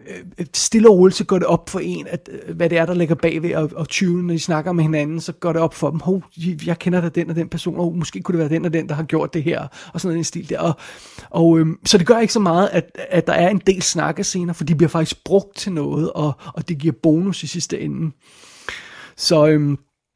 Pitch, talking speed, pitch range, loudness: 170 Hz, 270 wpm, 160-180 Hz, -18 LUFS